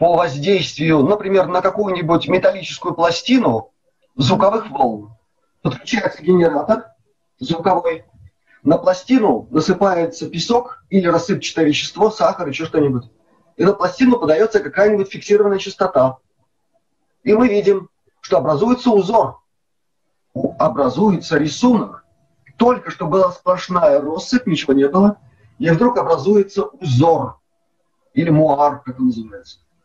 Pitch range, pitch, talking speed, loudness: 155-205 Hz, 180 Hz, 110 wpm, -16 LUFS